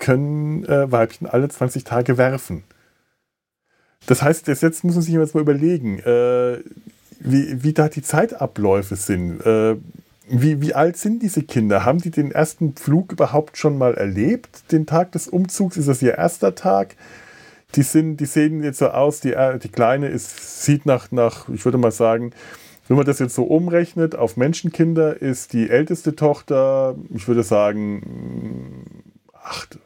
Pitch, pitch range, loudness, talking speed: 135 Hz, 120-155 Hz, -19 LUFS, 165 wpm